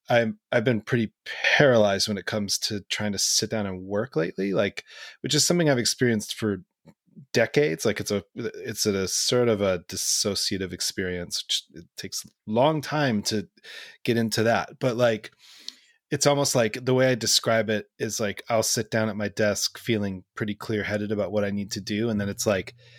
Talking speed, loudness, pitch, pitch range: 200 wpm, -25 LUFS, 110 Hz, 100-125 Hz